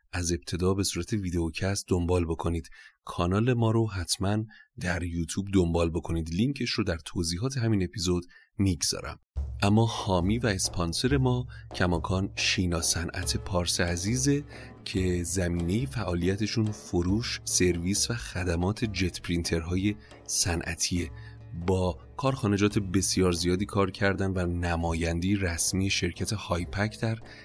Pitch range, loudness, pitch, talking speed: 85-110 Hz, -28 LUFS, 95 Hz, 120 wpm